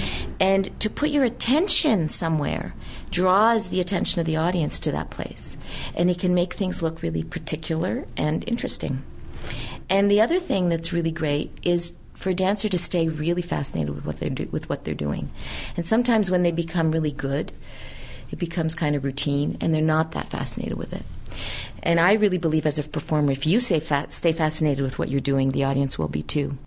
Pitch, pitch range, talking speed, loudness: 165 Hz, 145-185 Hz, 200 wpm, -23 LUFS